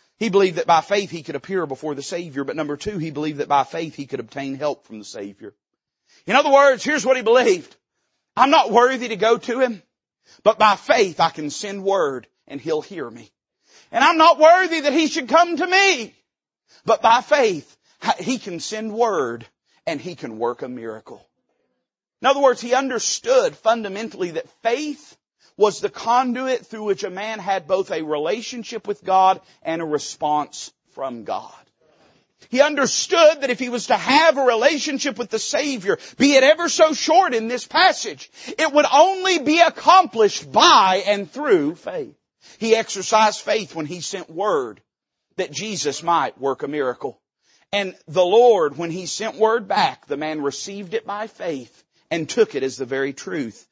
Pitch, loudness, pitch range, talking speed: 220 Hz, -19 LUFS, 170-275 Hz, 185 wpm